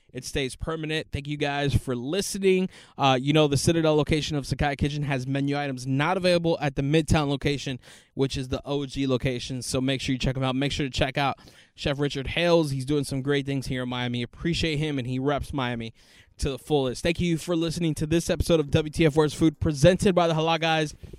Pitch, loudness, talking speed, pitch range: 145 Hz, -25 LUFS, 225 wpm, 135-160 Hz